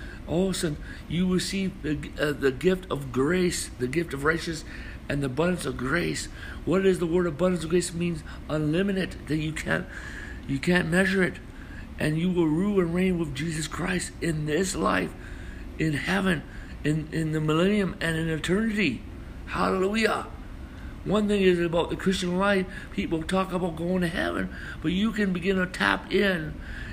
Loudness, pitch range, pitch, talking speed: -26 LUFS, 155-185 Hz, 170 Hz, 180 wpm